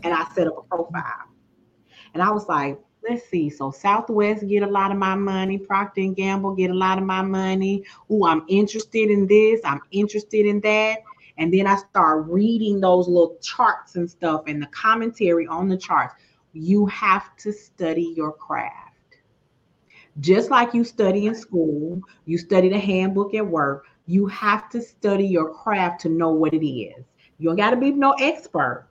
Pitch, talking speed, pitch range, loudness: 195 Hz, 185 wpm, 170-210 Hz, -21 LUFS